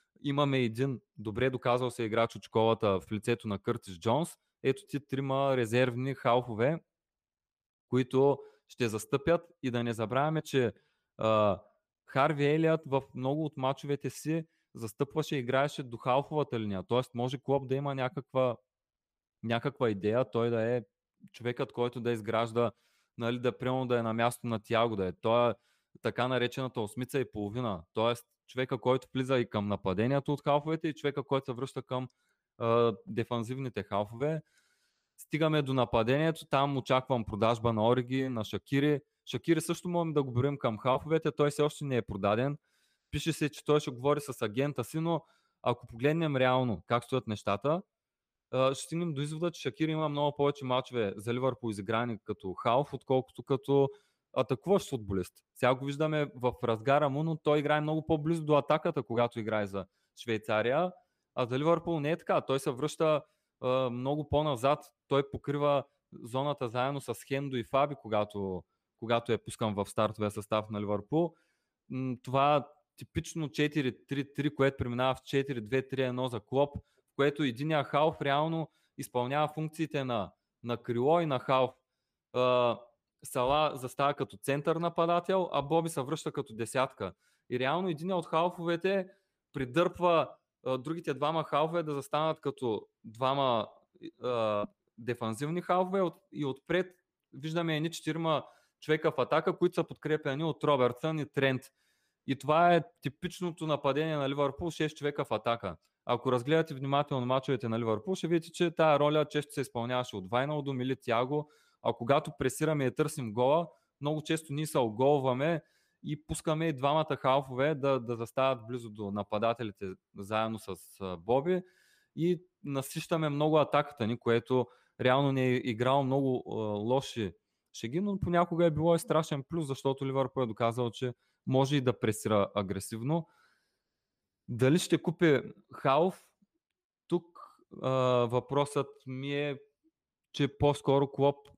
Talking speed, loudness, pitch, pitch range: 150 wpm, -32 LUFS, 135 Hz, 120-150 Hz